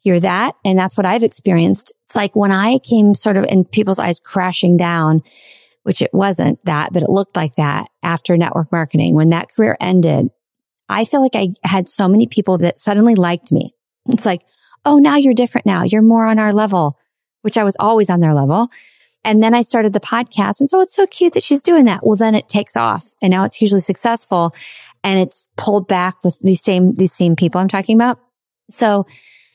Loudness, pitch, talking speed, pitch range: -14 LUFS, 200 Hz, 215 wpm, 180-225 Hz